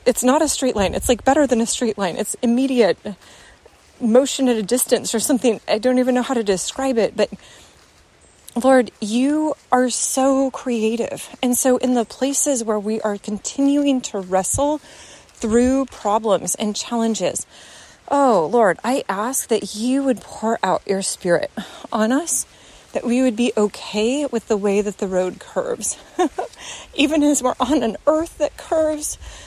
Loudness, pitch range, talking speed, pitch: -19 LUFS, 215-270 Hz, 165 wpm, 245 Hz